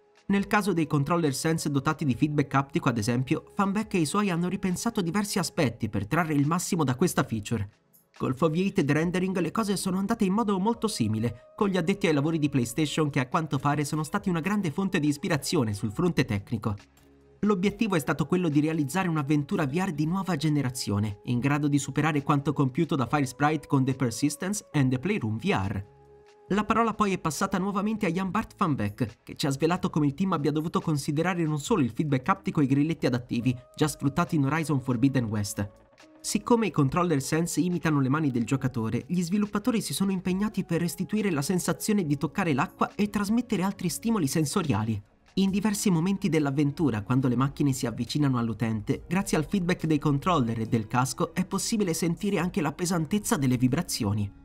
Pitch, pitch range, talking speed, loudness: 160 Hz, 135-190 Hz, 190 wpm, -27 LUFS